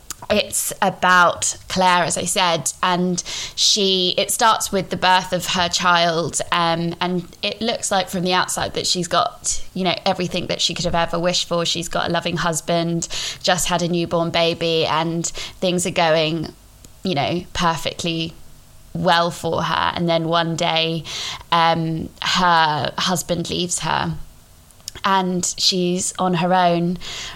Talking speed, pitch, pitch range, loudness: 155 wpm, 175 Hz, 165-180 Hz, -19 LUFS